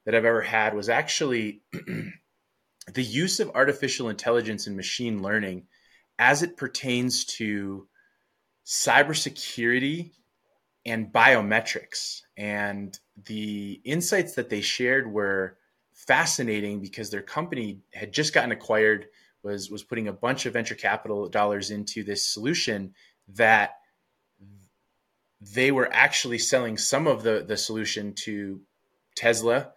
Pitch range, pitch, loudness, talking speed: 100-125 Hz, 110 Hz, -25 LUFS, 120 wpm